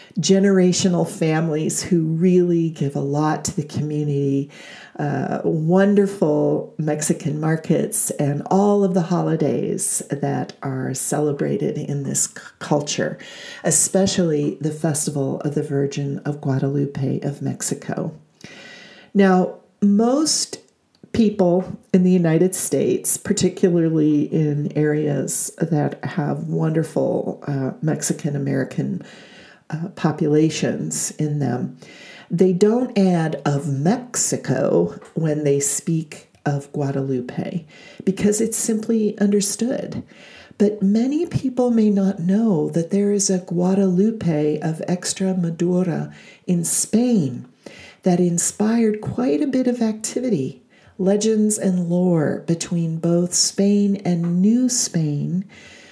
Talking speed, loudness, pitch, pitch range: 110 wpm, -20 LUFS, 175 Hz, 150-195 Hz